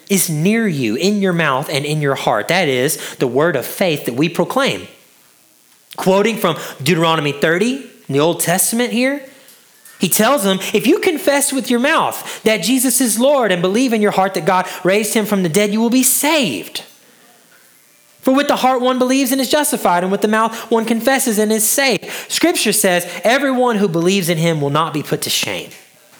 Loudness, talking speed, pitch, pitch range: -15 LUFS, 200 wpm, 215 Hz, 180-260 Hz